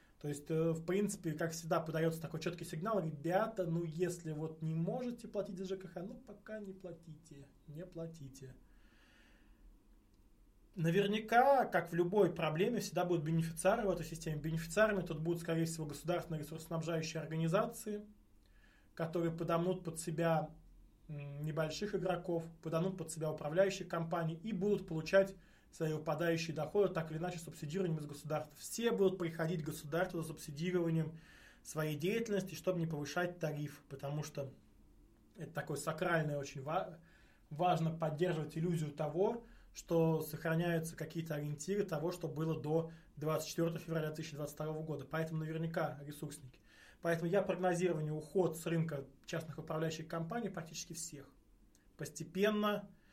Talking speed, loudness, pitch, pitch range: 135 wpm, -38 LUFS, 165 Hz, 155-180 Hz